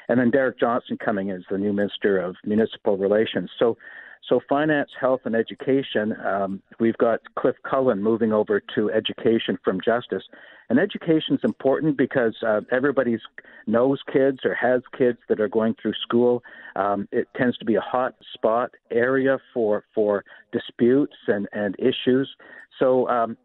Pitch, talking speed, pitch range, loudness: 120 Hz, 165 wpm, 105-135 Hz, -23 LUFS